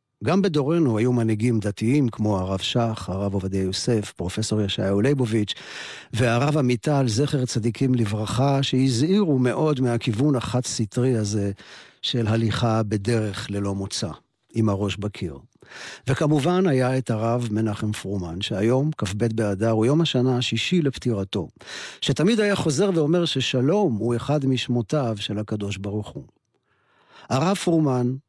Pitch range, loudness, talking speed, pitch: 105-135 Hz, -23 LUFS, 130 wpm, 120 Hz